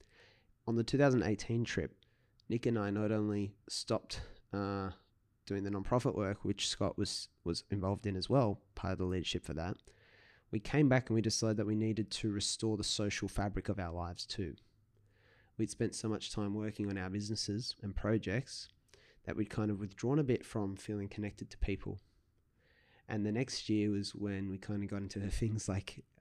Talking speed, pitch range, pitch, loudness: 190 wpm, 100-110 Hz, 105 Hz, -37 LUFS